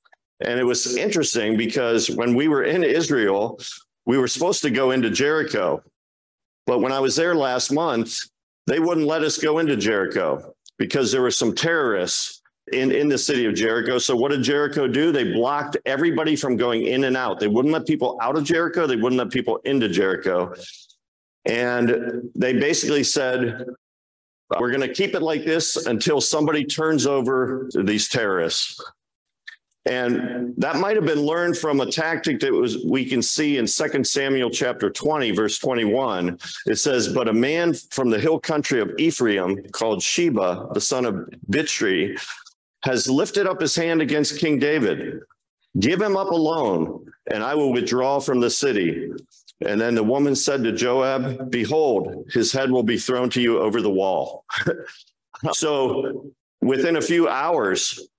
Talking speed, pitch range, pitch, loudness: 170 wpm, 120-155 Hz, 135 Hz, -21 LUFS